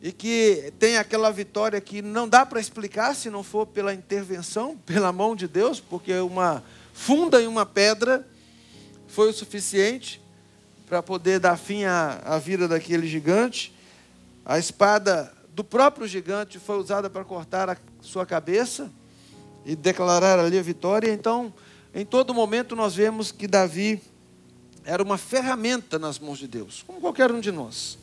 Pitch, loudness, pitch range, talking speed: 200 Hz, -24 LUFS, 175-220 Hz, 155 wpm